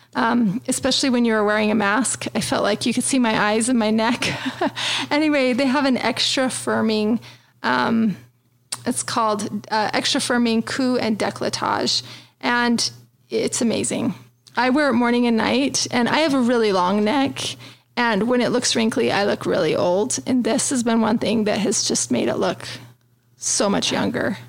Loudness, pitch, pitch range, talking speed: -20 LUFS, 230 Hz, 210-250 Hz, 180 wpm